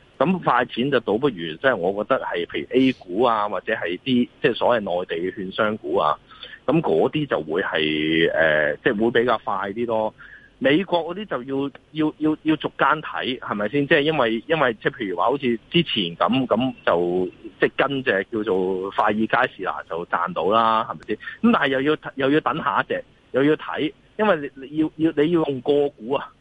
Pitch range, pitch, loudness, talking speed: 110-155 Hz, 130 Hz, -22 LUFS, 290 characters per minute